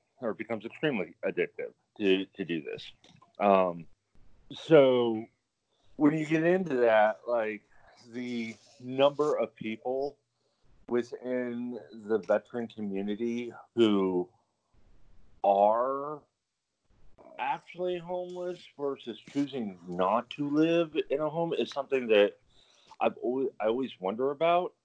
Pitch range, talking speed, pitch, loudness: 105-145 Hz, 110 wpm, 120 Hz, -30 LUFS